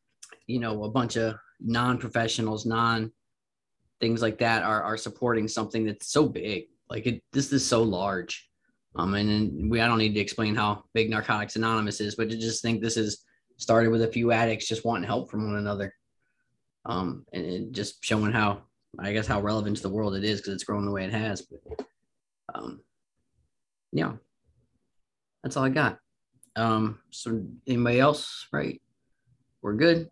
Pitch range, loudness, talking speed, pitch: 105-115 Hz, -27 LUFS, 175 wpm, 110 Hz